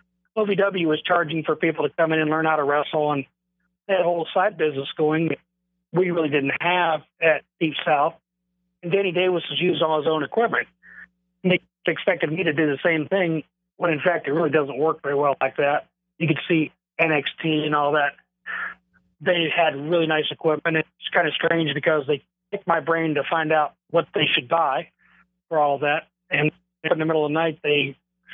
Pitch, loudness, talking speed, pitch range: 160 Hz, -22 LUFS, 205 wpm, 150-180 Hz